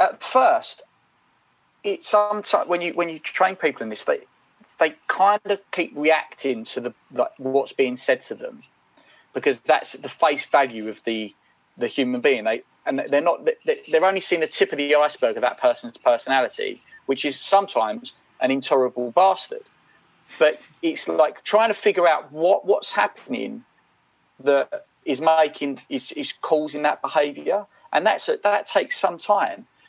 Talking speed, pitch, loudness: 165 wpm, 185 Hz, -22 LUFS